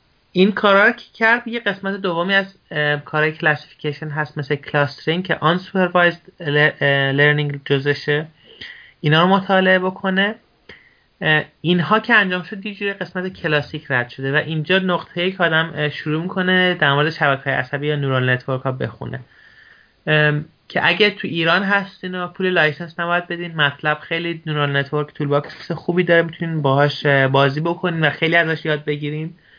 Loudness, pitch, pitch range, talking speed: -18 LUFS, 160 Hz, 150-185 Hz, 150 wpm